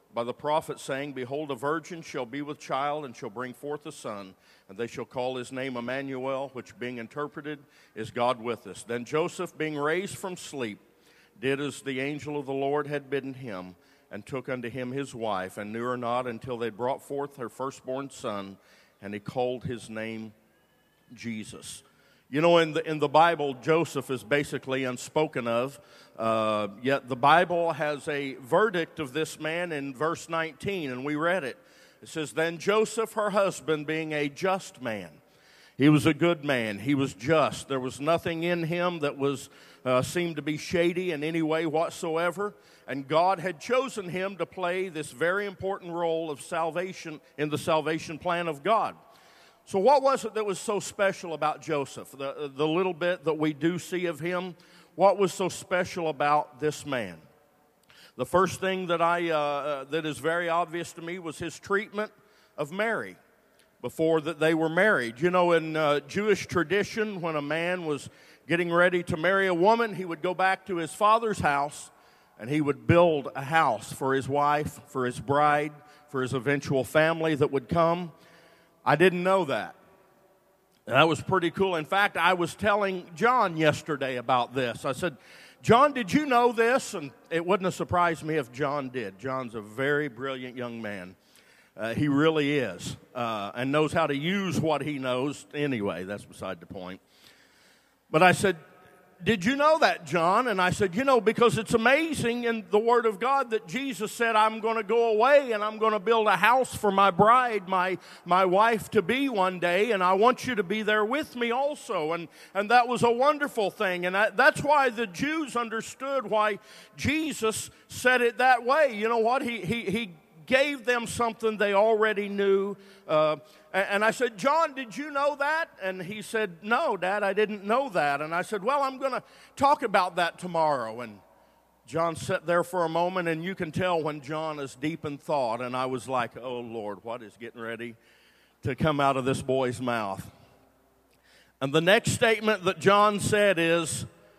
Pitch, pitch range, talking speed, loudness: 165 Hz, 140-200 Hz, 190 wpm, -27 LUFS